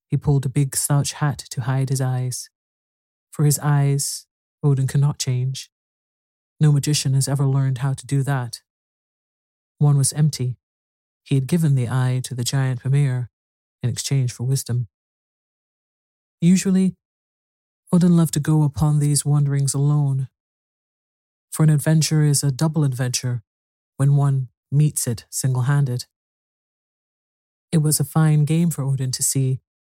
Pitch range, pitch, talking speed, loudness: 125-145 Hz, 135 Hz, 145 wpm, -20 LUFS